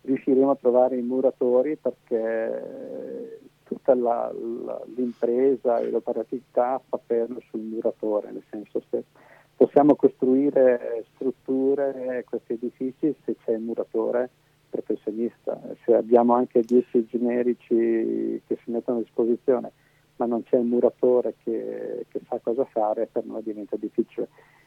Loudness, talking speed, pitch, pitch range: -25 LUFS, 130 wpm, 120 Hz, 115-130 Hz